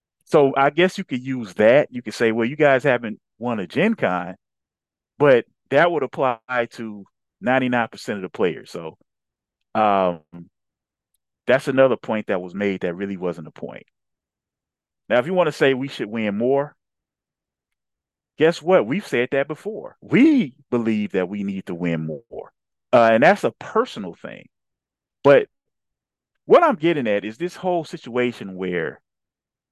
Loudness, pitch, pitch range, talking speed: -20 LUFS, 120 Hz, 100-150 Hz, 160 wpm